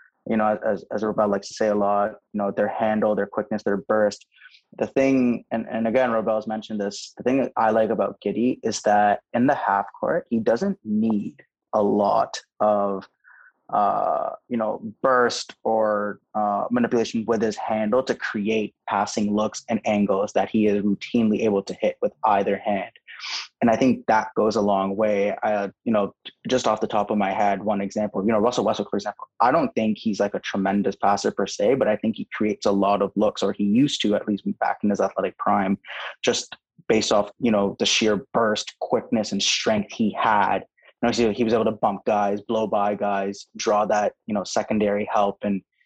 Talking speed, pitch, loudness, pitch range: 205 wpm, 105 Hz, -23 LUFS, 100-110 Hz